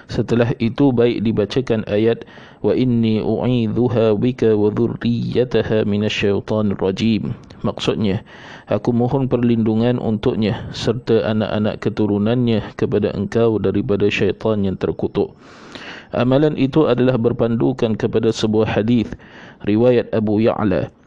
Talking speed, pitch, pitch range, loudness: 105 wpm, 115 Hz, 105-120 Hz, -18 LUFS